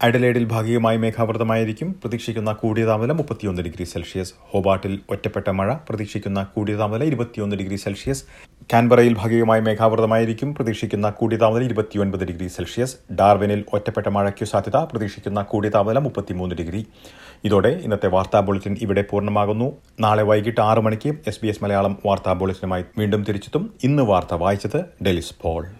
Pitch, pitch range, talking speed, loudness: 105 Hz, 100-115 Hz, 135 wpm, -21 LUFS